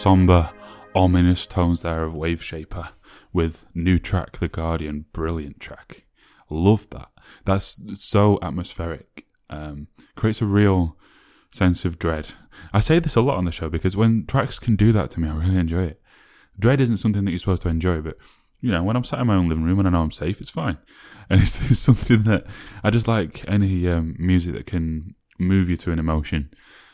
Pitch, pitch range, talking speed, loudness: 90 Hz, 80-100 Hz, 200 wpm, -21 LUFS